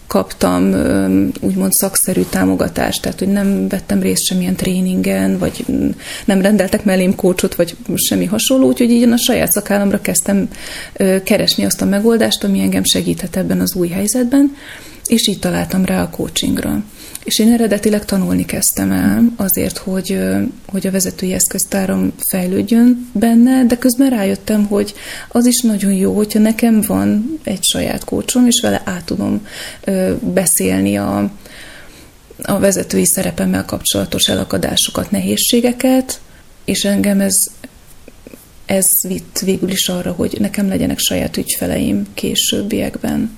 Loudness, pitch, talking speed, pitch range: -14 LUFS, 195 Hz, 135 wpm, 175-220 Hz